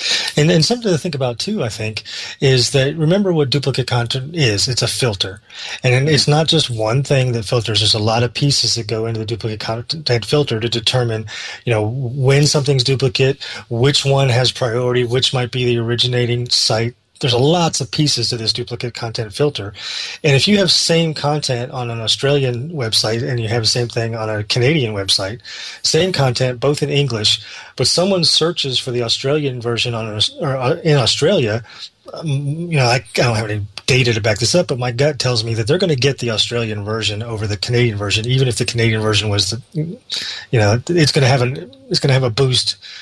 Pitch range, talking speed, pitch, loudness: 115-145 Hz, 210 wpm, 125 Hz, -16 LUFS